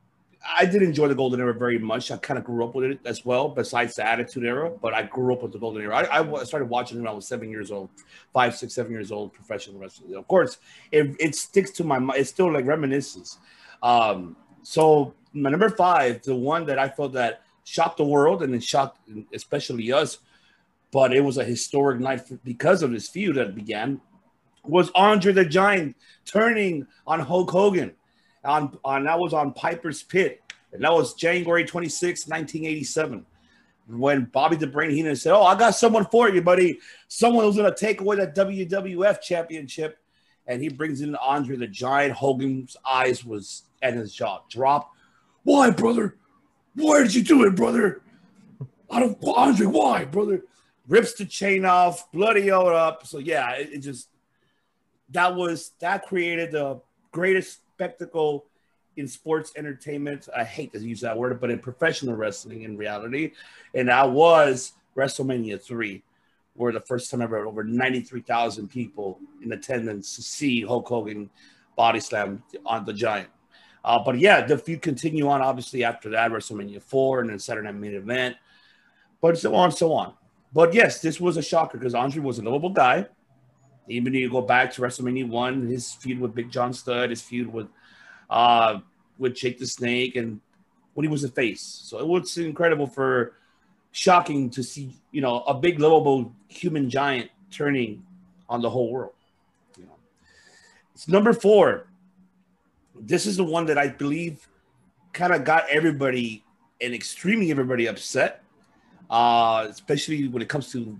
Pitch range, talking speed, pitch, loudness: 120-175 Hz, 180 wpm, 140 Hz, -23 LUFS